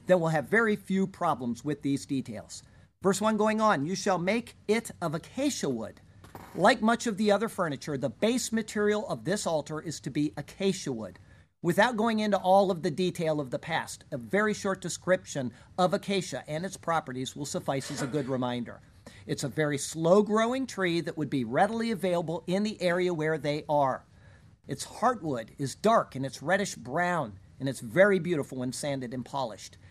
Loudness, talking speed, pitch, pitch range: -29 LUFS, 190 wpm, 165 Hz, 140-195 Hz